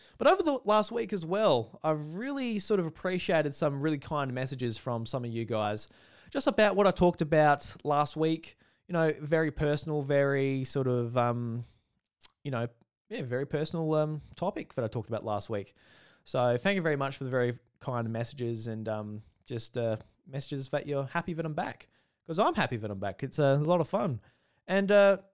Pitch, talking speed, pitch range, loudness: 145 Hz, 200 wpm, 120-170 Hz, -30 LUFS